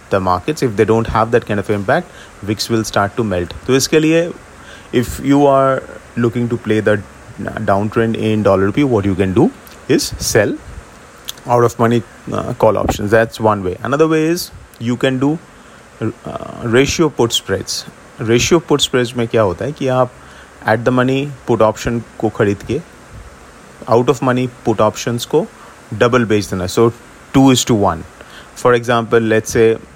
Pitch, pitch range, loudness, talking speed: 115 Hz, 105-130 Hz, -15 LUFS, 170 wpm